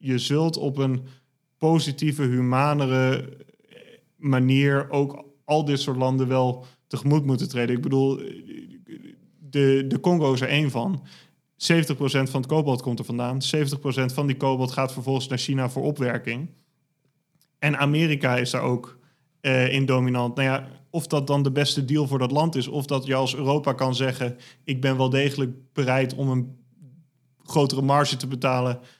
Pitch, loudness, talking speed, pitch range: 135 Hz, -24 LUFS, 165 wpm, 130-145 Hz